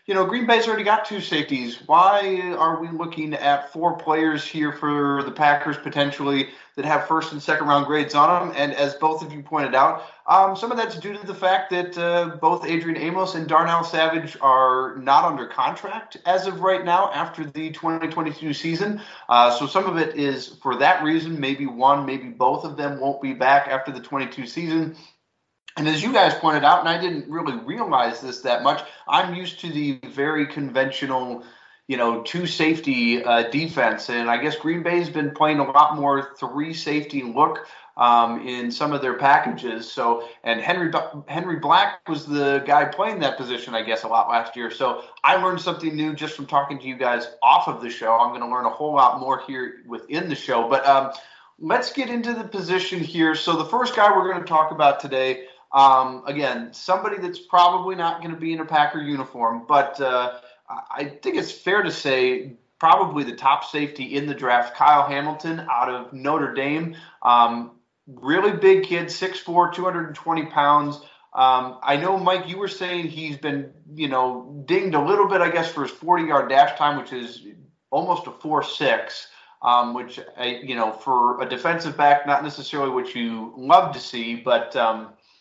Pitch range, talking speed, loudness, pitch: 135-170 Hz, 195 wpm, -21 LUFS, 150 Hz